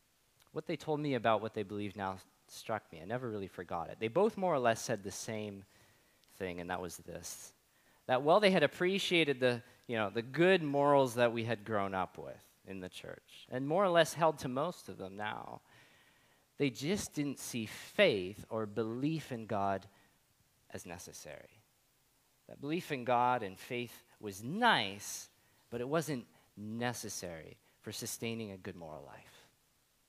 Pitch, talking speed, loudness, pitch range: 115 Hz, 175 wpm, -35 LUFS, 100-140 Hz